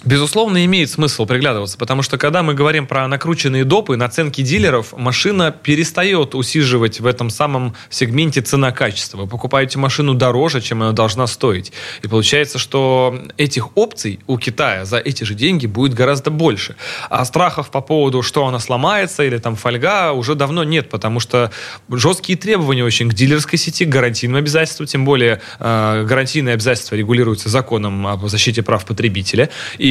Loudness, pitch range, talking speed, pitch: -15 LUFS, 120-150 Hz, 160 wpm, 130 Hz